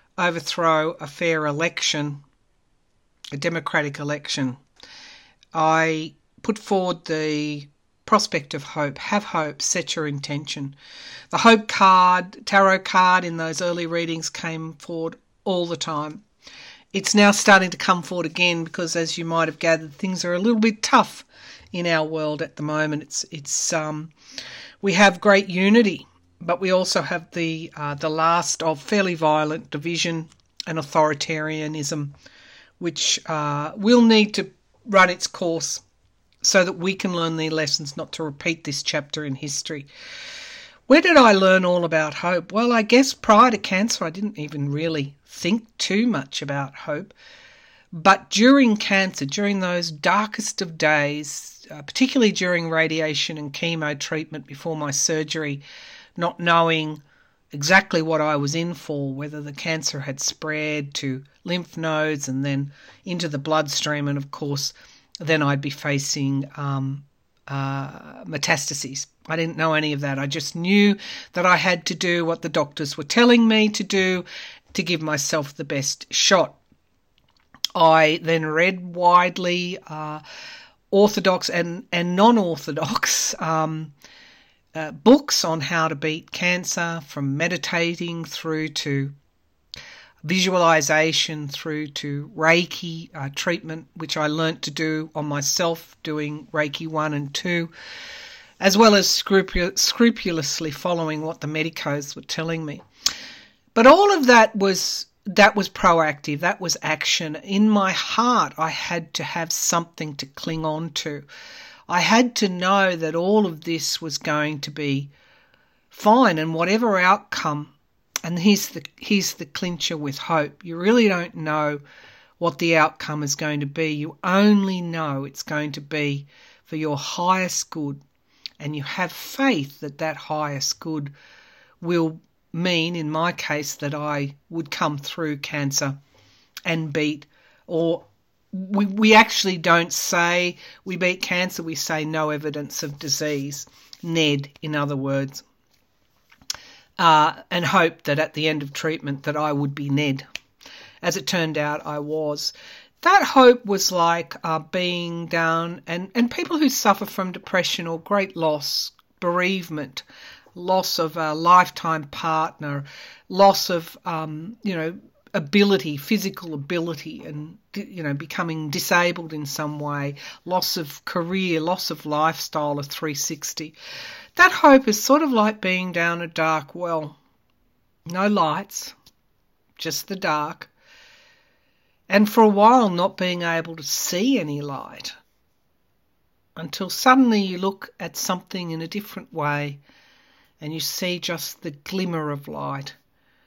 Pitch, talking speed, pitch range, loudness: 165 Hz, 145 wpm, 150-185 Hz, -21 LUFS